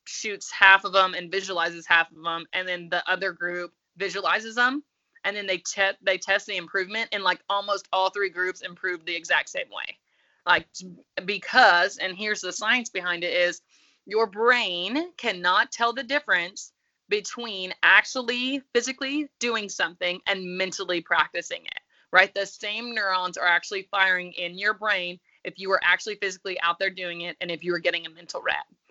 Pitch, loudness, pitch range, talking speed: 190 Hz, -24 LUFS, 180-225 Hz, 180 wpm